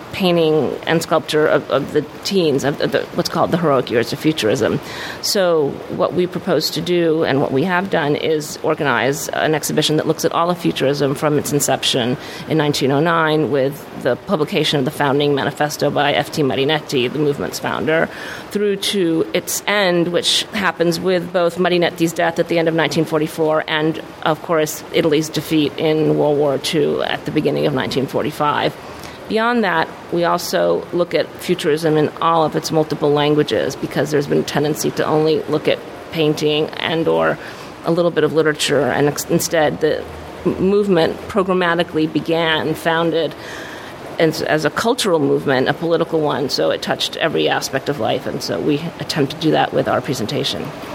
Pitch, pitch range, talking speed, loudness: 155 Hz, 150-170 Hz, 175 wpm, -17 LUFS